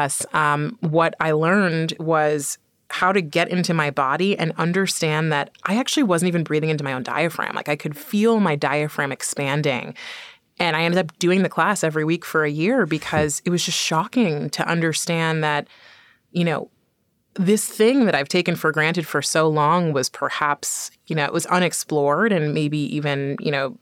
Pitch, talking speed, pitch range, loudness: 165 Hz, 185 wpm, 150-180 Hz, -21 LUFS